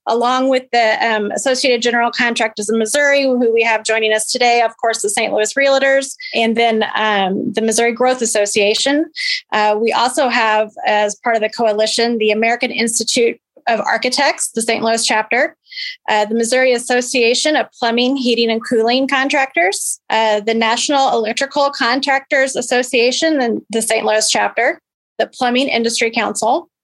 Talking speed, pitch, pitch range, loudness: 160 wpm, 235 Hz, 225-270 Hz, -15 LUFS